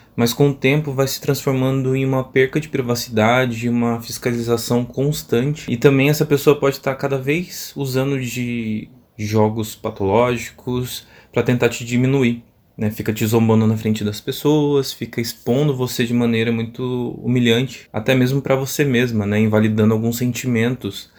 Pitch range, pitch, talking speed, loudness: 115-135 Hz, 120 Hz, 155 wpm, -19 LUFS